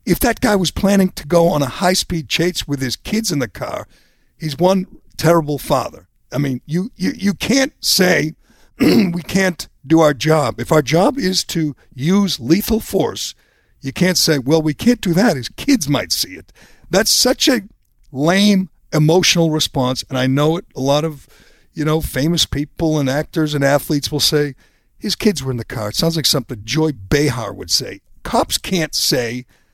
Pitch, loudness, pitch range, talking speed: 155 Hz, -17 LUFS, 145-185 Hz, 190 wpm